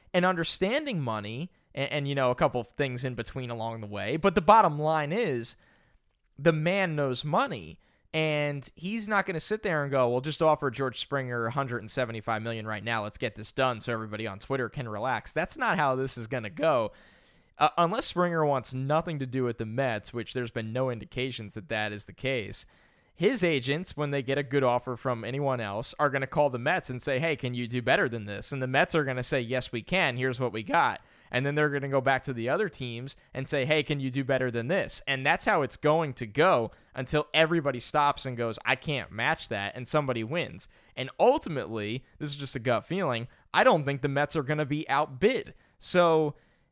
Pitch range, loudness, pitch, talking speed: 120-150 Hz, -28 LUFS, 135 Hz, 230 wpm